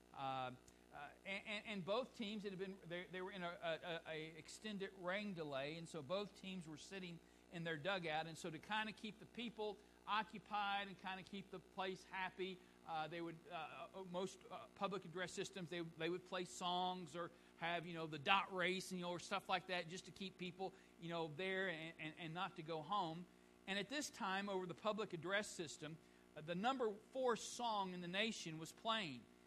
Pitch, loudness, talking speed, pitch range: 185 Hz, -47 LUFS, 210 wpm, 165-195 Hz